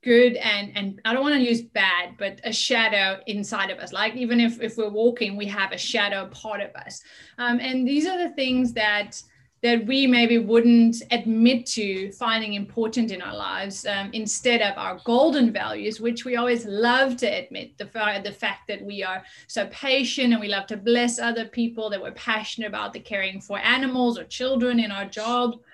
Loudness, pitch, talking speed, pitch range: -23 LUFS, 225 Hz, 200 wpm, 205-240 Hz